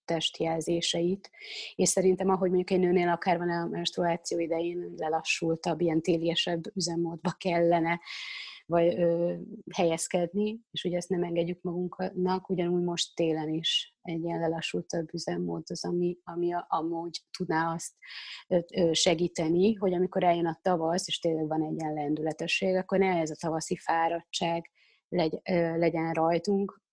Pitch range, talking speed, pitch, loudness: 165-180 Hz, 135 wpm, 170 Hz, -29 LUFS